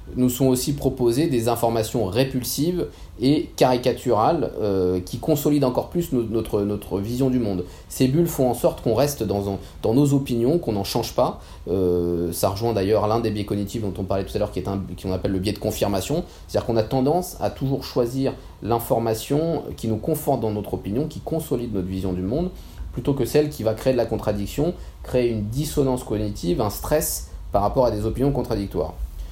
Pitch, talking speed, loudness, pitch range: 115 Hz, 205 wpm, -23 LUFS, 100-135 Hz